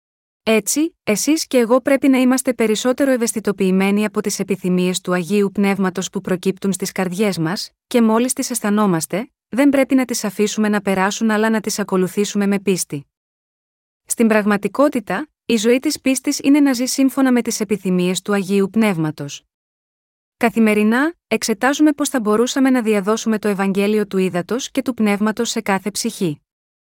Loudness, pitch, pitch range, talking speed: -18 LUFS, 215 Hz, 195-250 Hz, 155 wpm